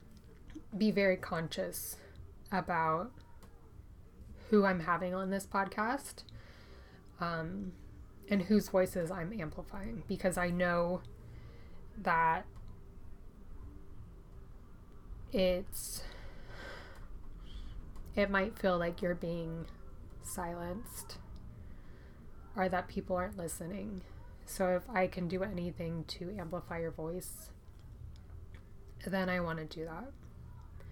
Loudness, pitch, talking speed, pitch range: -36 LUFS, 175 Hz, 95 wpm, 115-190 Hz